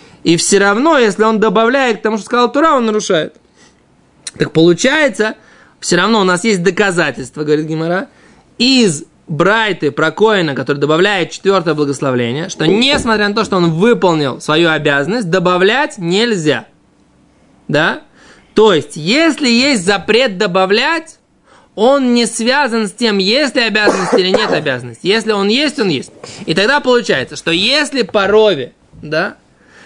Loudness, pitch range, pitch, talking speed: -12 LUFS, 170-235 Hz, 205 Hz, 145 wpm